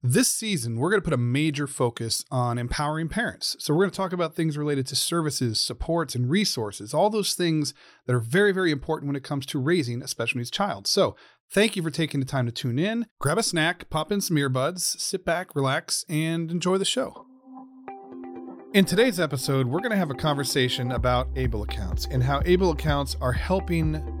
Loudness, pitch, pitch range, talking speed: -25 LUFS, 150 Hz, 125-180 Hz, 210 wpm